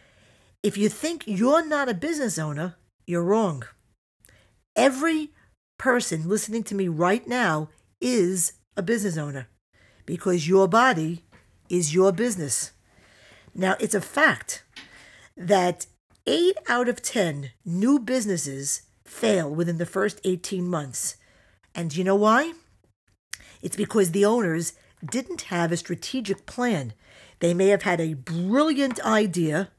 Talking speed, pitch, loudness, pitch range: 130 wpm, 185 Hz, -24 LUFS, 160-225 Hz